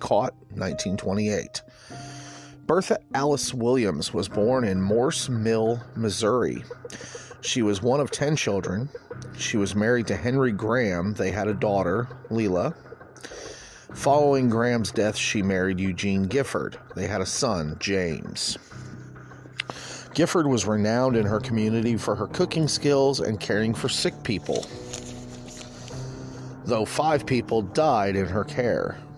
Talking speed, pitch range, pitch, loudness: 130 wpm, 105-130 Hz, 115 Hz, -25 LUFS